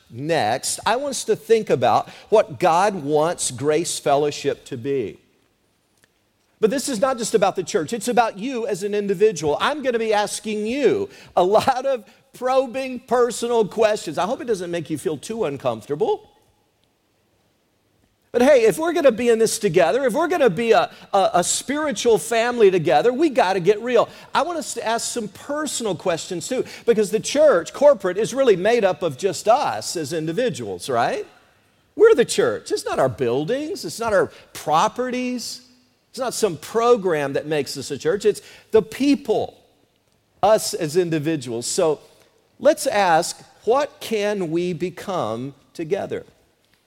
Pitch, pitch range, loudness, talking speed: 225 Hz, 180-270 Hz, -20 LUFS, 170 wpm